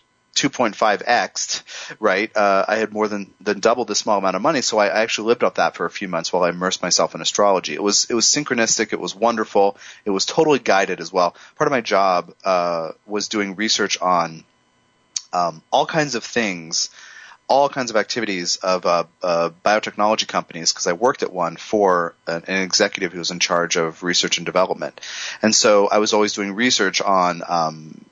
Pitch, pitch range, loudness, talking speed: 100 Hz, 90-110 Hz, -19 LUFS, 205 wpm